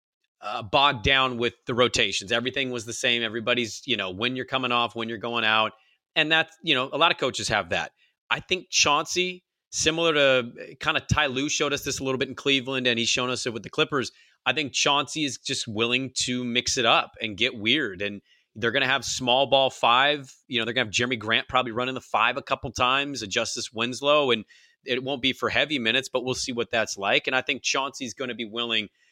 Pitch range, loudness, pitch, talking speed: 120-140 Hz, -24 LUFS, 125 Hz, 235 wpm